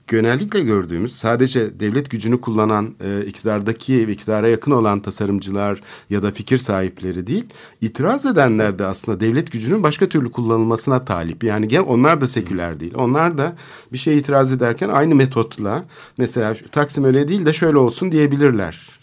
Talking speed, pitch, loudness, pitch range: 160 wpm, 115 Hz, -18 LUFS, 105-140 Hz